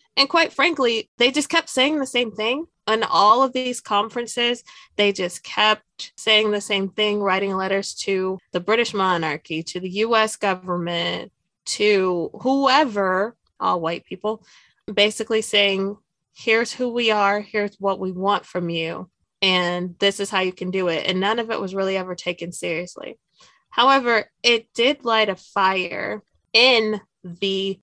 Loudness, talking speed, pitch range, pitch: -21 LUFS, 160 wpm, 185-230 Hz, 205 Hz